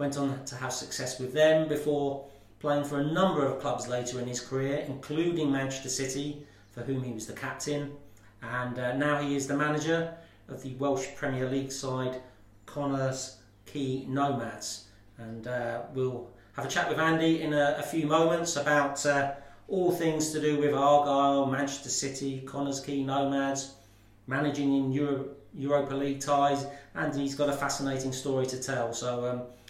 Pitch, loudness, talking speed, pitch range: 140 Hz, -30 LUFS, 170 wpm, 130-145 Hz